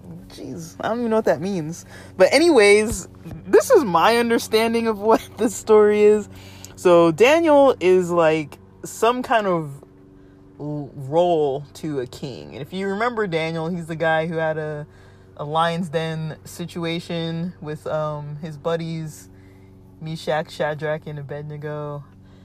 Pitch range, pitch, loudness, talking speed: 145-190 Hz, 160 Hz, -20 LUFS, 140 wpm